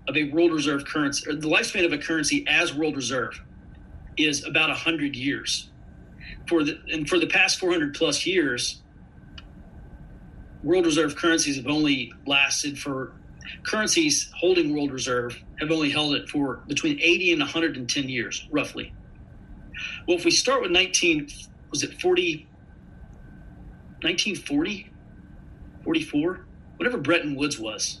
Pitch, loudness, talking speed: 155 Hz, -23 LUFS, 140 wpm